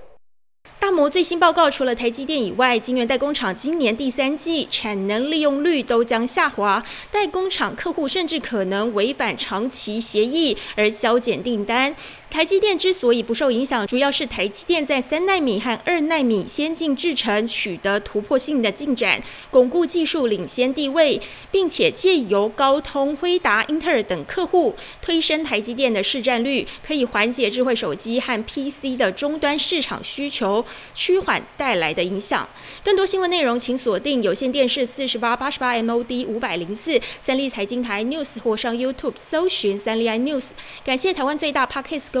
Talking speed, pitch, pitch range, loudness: 295 characters per minute, 265 Hz, 230-310 Hz, -20 LUFS